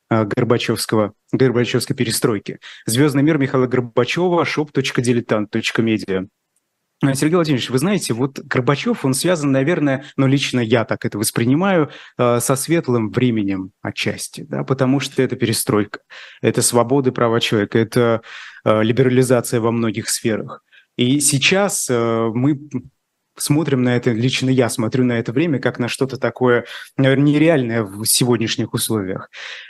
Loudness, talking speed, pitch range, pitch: -18 LUFS, 125 wpm, 115-140 Hz, 125 Hz